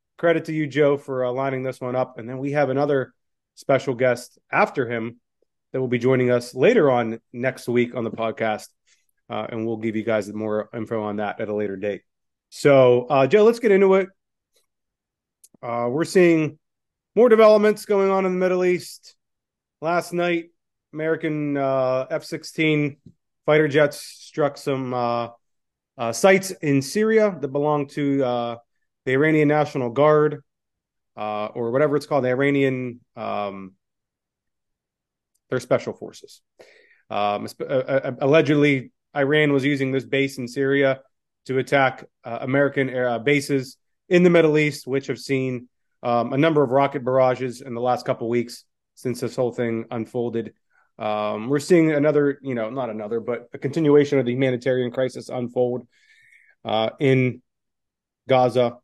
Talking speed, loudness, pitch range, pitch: 160 wpm, -21 LUFS, 120-150 Hz, 135 Hz